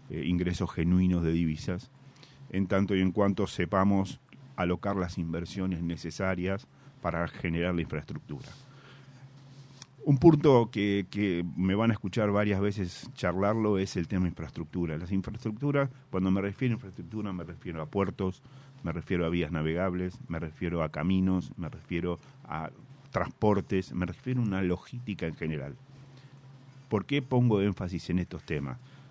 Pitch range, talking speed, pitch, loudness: 90-130 Hz, 150 wpm, 95 Hz, -30 LUFS